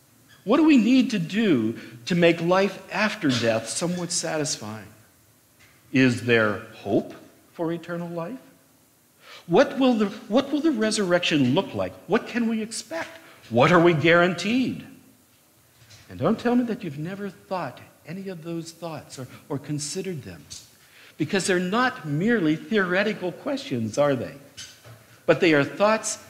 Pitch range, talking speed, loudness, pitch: 135-215 Hz, 145 wpm, -23 LUFS, 175 Hz